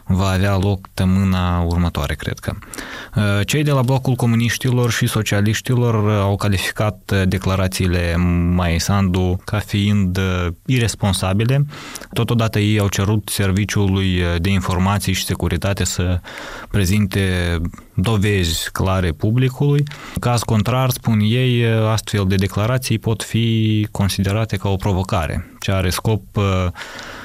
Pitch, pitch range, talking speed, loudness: 100 Hz, 95-110 Hz, 115 wpm, -18 LUFS